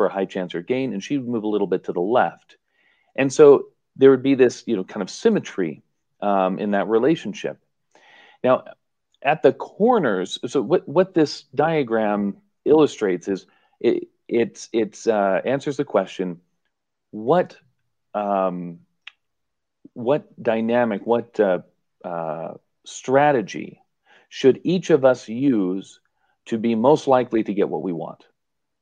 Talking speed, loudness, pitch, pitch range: 150 wpm, -21 LUFS, 120 Hz, 100-145 Hz